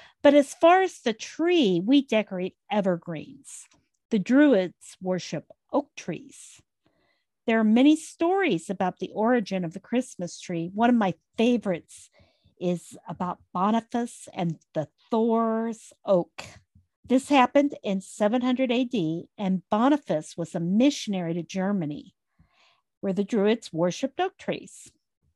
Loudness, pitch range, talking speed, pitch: -25 LUFS, 180-255 Hz, 130 wpm, 210 Hz